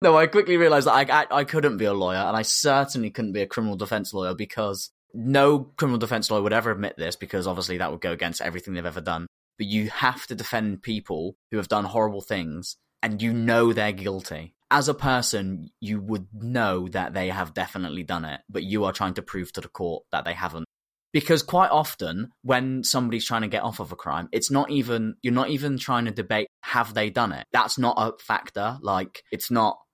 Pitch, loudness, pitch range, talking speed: 110 Hz, -25 LUFS, 100-130 Hz, 225 wpm